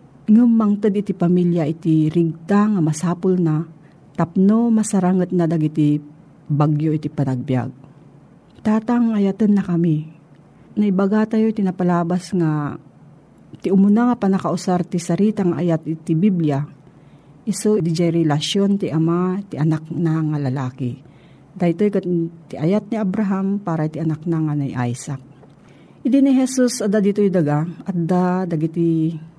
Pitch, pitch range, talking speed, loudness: 170 Hz, 155-200 Hz, 140 wpm, -19 LUFS